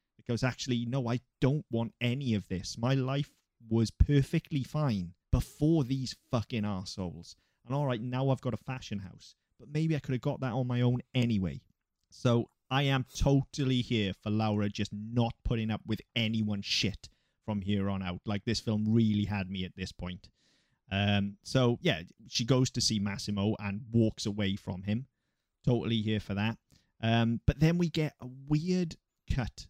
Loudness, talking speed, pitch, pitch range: -32 LUFS, 185 wpm, 115 Hz, 105-130 Hz